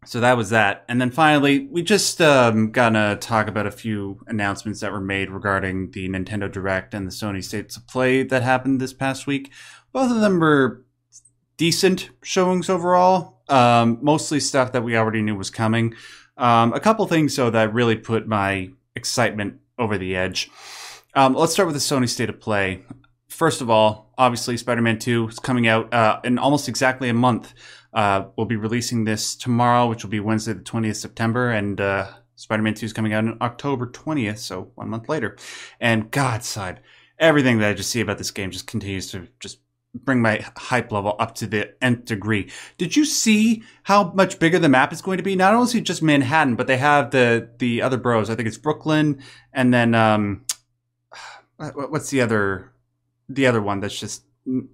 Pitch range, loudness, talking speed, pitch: 110-135 Hz, -20 LUFS, 195 wpm, 120 Hz